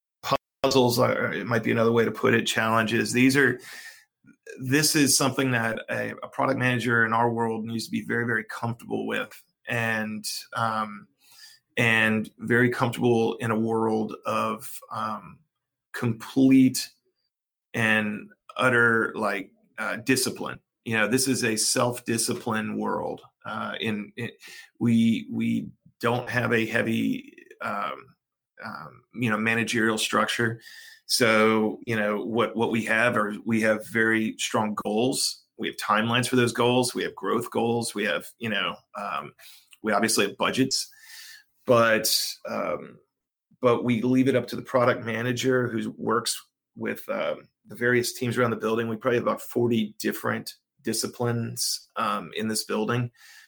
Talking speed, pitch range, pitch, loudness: 150 wpm, 110-125 Hz, 120 Hz, -25 LUFS